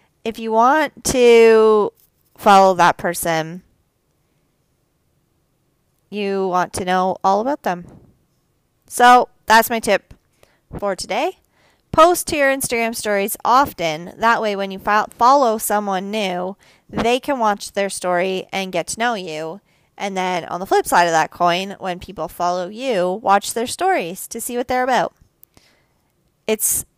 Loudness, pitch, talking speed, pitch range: -17 LUFS, 200 Hz, 145 wpm, 180-230 Hz